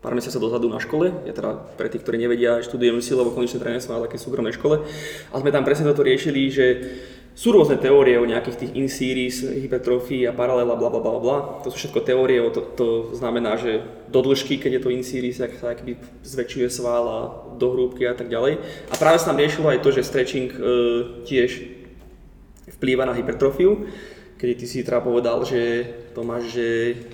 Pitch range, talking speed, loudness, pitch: 120-130 Hz, 200 wpm, -21 LUFS, 125 Hz